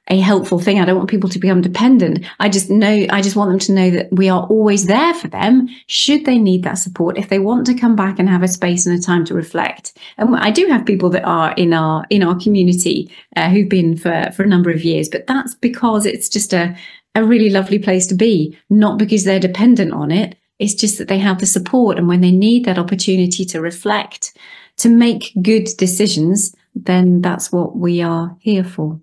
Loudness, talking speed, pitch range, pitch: -14 LUFS, 230 wpm, 180-215 Hz, 195 Hz